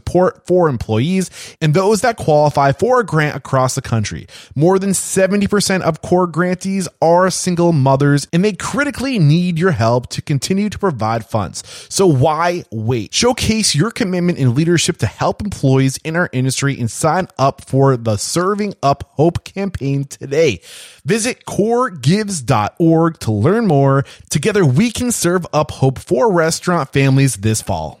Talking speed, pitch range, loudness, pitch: 155 wpm, 135-190 Hz, -15 LUFS, 160 Hz